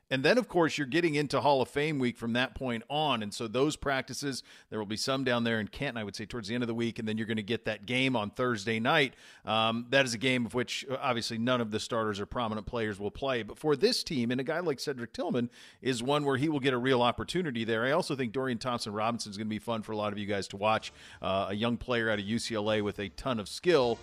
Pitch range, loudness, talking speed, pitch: 110-130 Hz, -31 LUFS, 285 wpm, 120 Hz